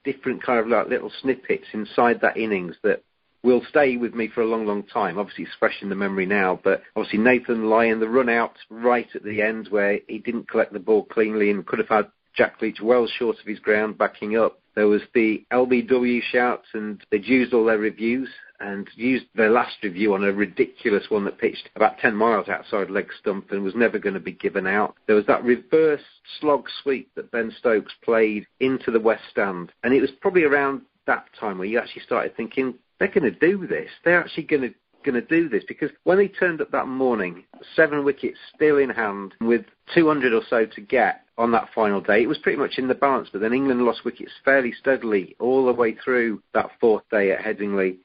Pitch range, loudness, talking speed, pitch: 110-135 Hz, -22 LUFS, 220 wpm, 120 Hz